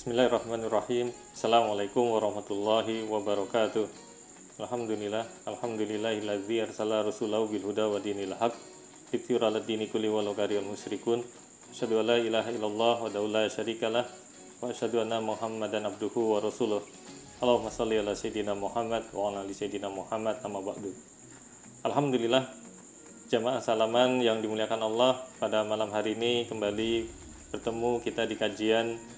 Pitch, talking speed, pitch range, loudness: 110 Hz, 120 wpm, 105-115 Hz, -30 LUFS